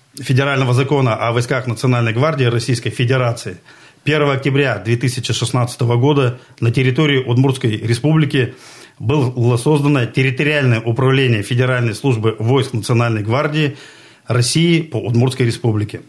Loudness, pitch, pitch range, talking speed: -16 LUFS, 125 Hz, 120-140 Hz, 110 wpm